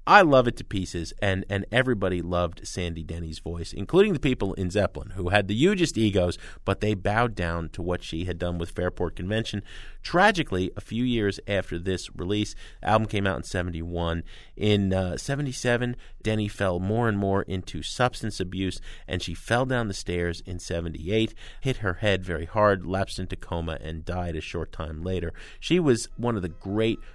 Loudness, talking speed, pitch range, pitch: -27 LUFS, 195 wpm, 85-110 Hz, 95 Hz